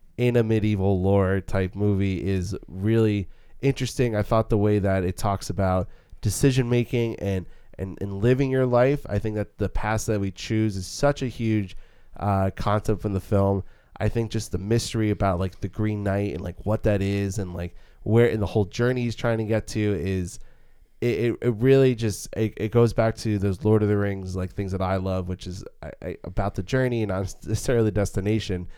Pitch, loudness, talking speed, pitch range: 105 Hz, -24 LUFS, 215 wpm, 95-115 Hz